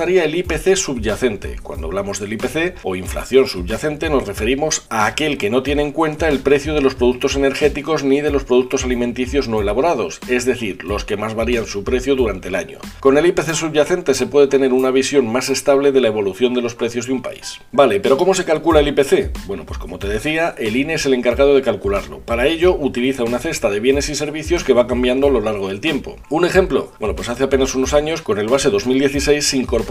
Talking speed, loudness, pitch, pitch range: 225 wpm, -17 LUFS, 135 Hz, 125-150 Hz